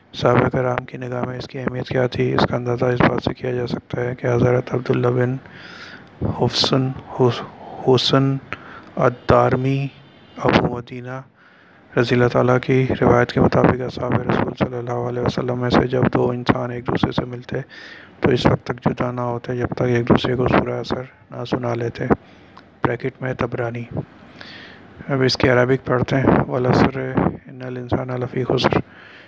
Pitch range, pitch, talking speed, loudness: 120-130 Hz, 125 Hz, 160 wpm, -20 LUFS